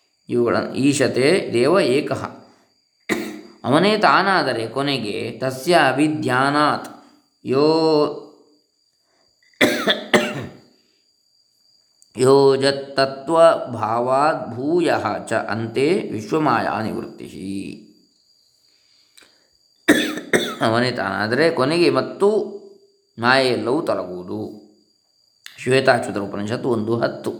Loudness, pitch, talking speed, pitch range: -19 LUFS, 135 Hz, 45 wpm, 115-155 Hz